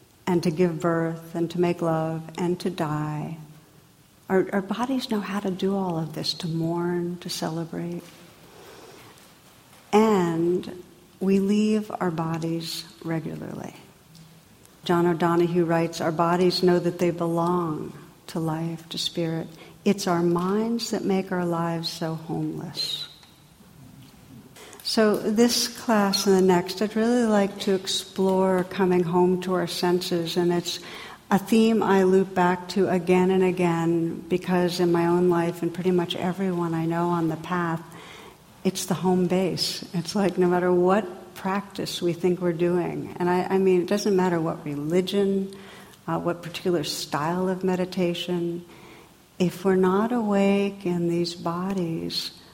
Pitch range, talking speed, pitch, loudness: 170-190 Hz, 150 wpm, 180 Hz, -24 LUFS